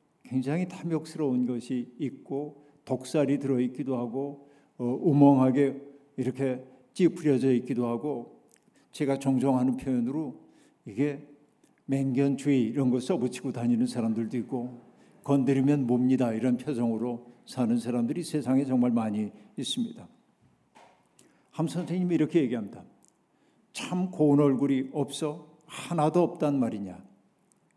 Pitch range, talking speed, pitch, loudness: 125-150 Hz, 285 characters per minute, 135 Hz, -28 LUFS